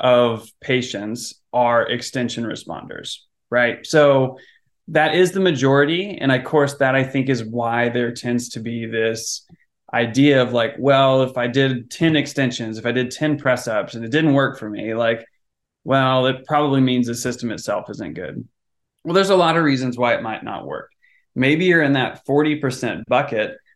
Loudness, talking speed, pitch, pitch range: -19 LUFS, 180 wpm, 130 Hz, 120-145 Hz